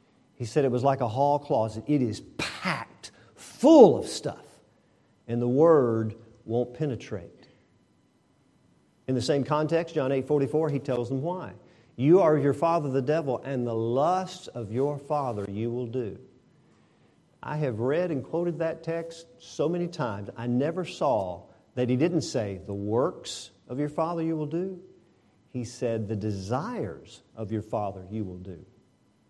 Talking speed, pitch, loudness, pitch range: 165 wpm, 130 Hz, -27 LUFS, 115-155 Hz